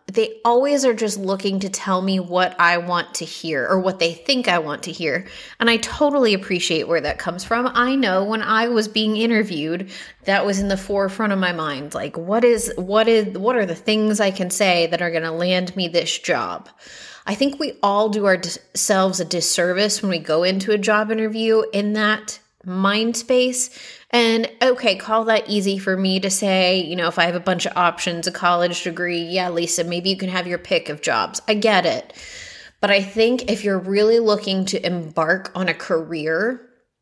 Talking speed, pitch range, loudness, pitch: 210 wpm, 175-220 Hz, -19 LUFS, 195 Hz